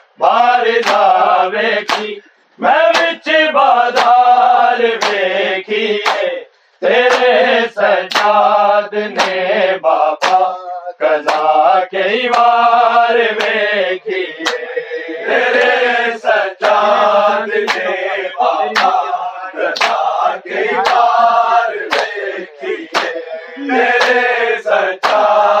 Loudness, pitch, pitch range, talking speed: -13 LUFS, 230 Hz, 205-250 Hz, 35 wpm